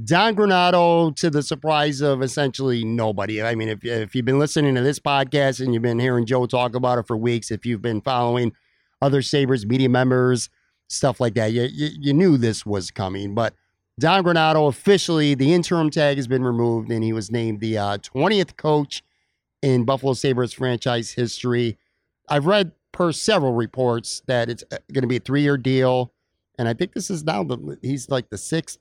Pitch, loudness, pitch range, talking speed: 130 Hz, -21 LUFS, 115-150 Hz, 195 wpm